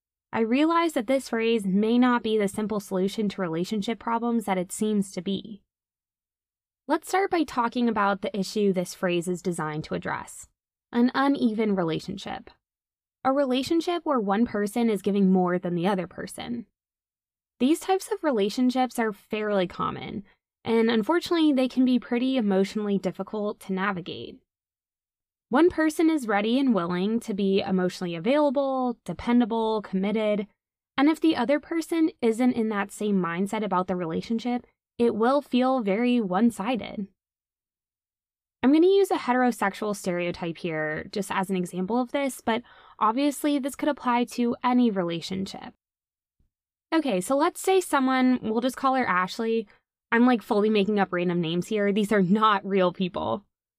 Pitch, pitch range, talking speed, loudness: 220 Hz, 195-255 Hz, 155 wpm, -25 LUFS